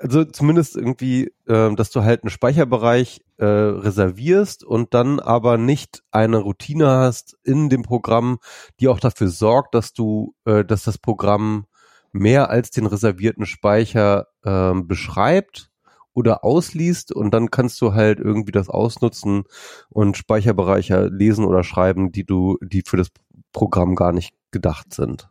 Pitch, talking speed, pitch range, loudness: 110 Hz, 140 wpm, 100-125 Hz, -18 LUFS